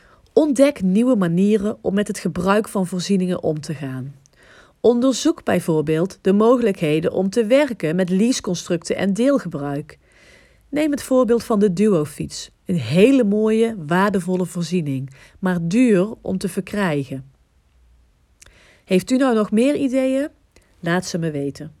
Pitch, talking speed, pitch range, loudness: 185 Hz, 135 wpm, 155-225 Hz, -19 LUFS